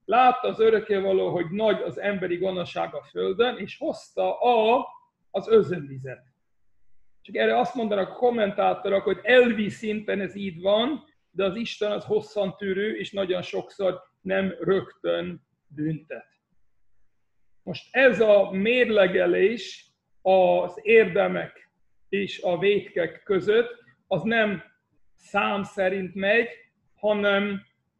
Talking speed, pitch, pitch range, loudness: 115 wpm, 200 Hz, 185-225 Hz, -24 LUFS